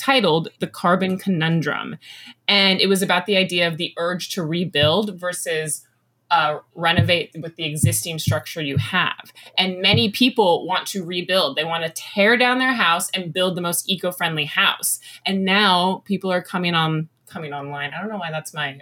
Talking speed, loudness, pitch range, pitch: 180 wpm, -20 LUFS, 160-190 Hz, 175 Hz